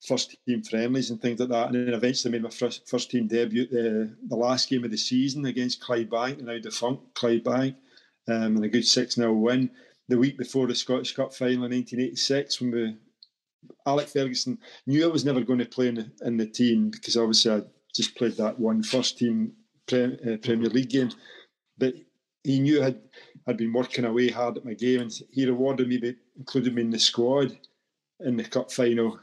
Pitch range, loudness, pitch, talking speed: 115-130 Hz, -26 LUFS, 125 Hz, 210 wpm